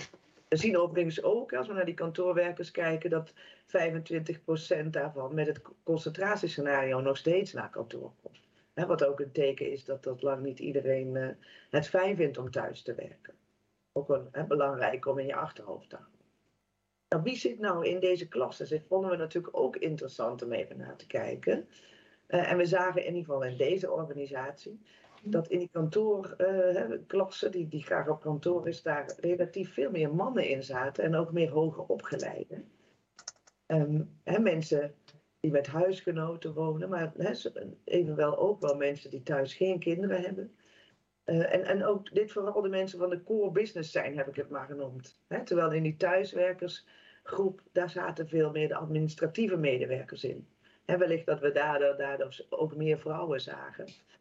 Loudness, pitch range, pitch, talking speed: -32 LUFS, 145-180 Hz, 165 Hz, 170 wpm